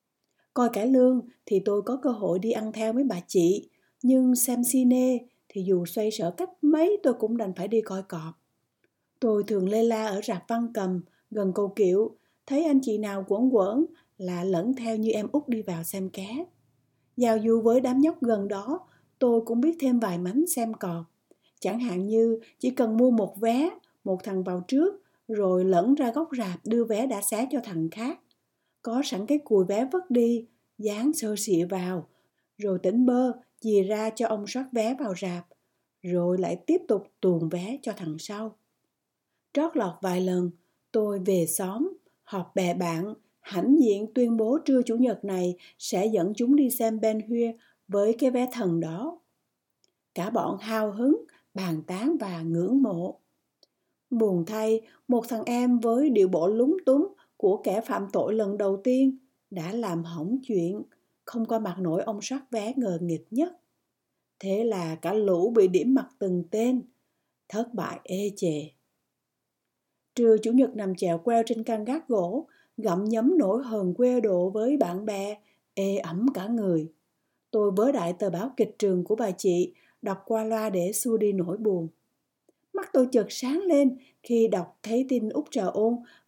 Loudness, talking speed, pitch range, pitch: -26 LUFS, 185 wpm, 195-255 Hz, 225 Hz